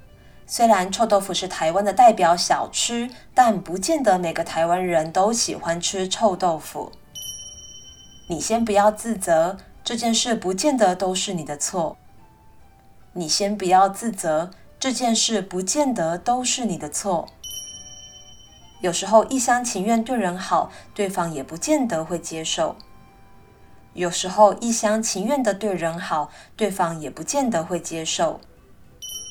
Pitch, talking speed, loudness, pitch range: 190 Hz, 210 characters per minute, -21 LUFS, 170-225 Hz